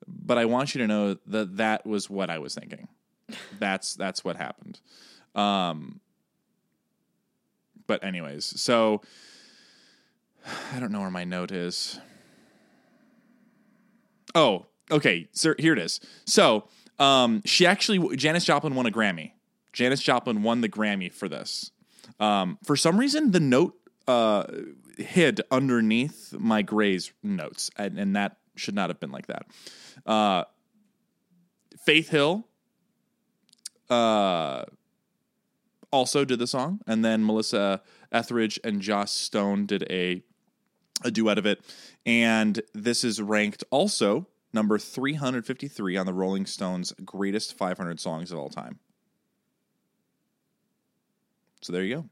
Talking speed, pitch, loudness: 130 wpm, 120 Hz, -26 LUFS